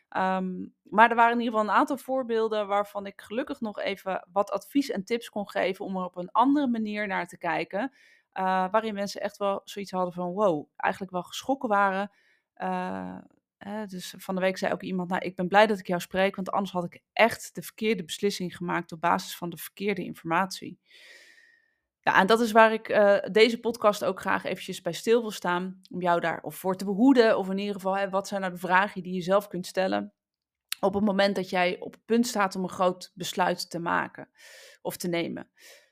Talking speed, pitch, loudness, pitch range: 215 wpm, 195 Hz, -27 LUFS, 180-215 Hz